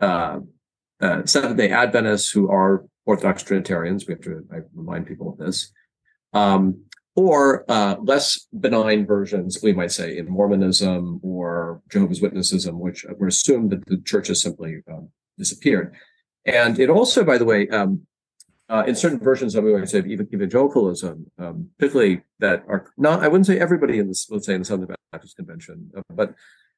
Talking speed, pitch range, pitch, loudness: 170 wpm, 95-140 Hz, 100 Hz, -20 LUFS